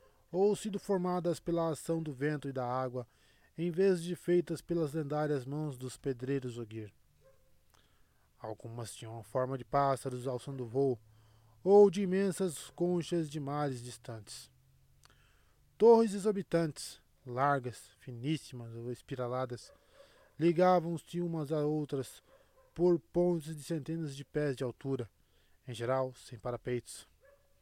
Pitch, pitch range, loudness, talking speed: 140 Hz, 125-170 Hz, -34 LUFS, 125 wpm